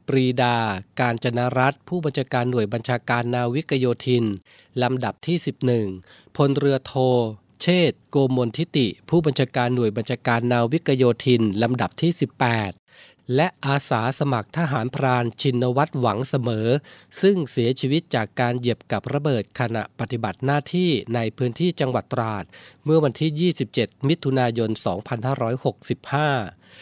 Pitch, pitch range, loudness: 125 Hz, 120-140 Hz, -22 LUFS